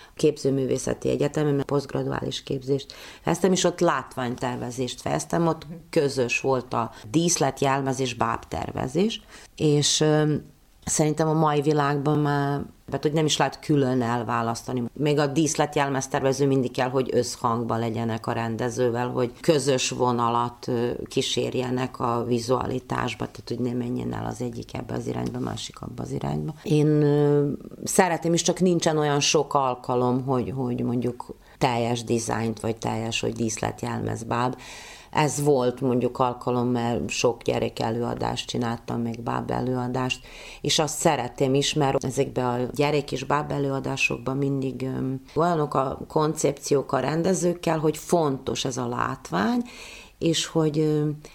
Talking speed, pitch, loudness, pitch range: 135 wpm, 135 Hz, -25 LUFS, 120-150 Hz